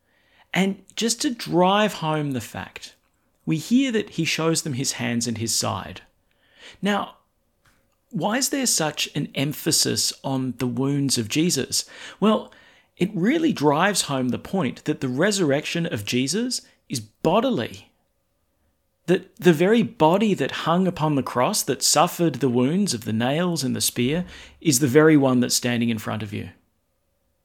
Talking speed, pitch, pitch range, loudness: 160 wpm, 150 Hz, 125-185 Hz, -22 LUFS